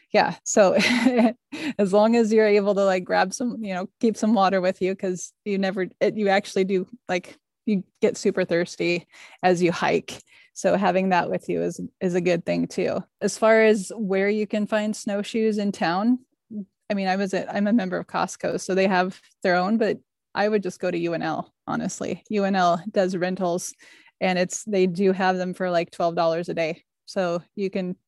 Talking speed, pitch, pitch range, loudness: 205 wpm, 195 Hz, 180-215 Hz, -23 LUFS